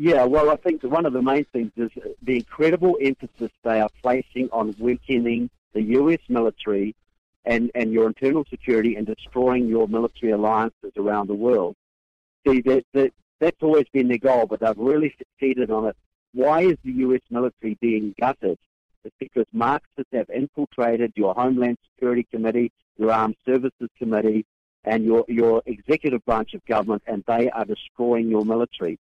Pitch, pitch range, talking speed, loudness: 120 Hz, 110-130 Hz, 165 wpm, -22 LUFS